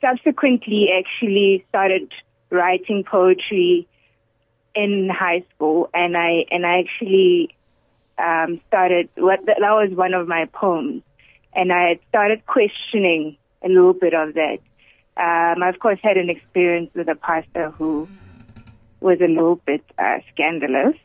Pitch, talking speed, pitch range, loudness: 175 Hz, 135 wpm, 160-195 Hz, -18 LUFS